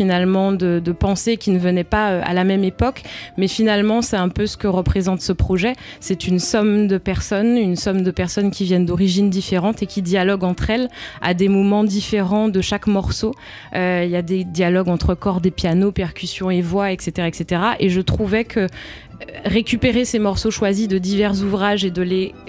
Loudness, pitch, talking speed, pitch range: -19 LUFS, 195 Hz, 205 wpm, 185-210 Hz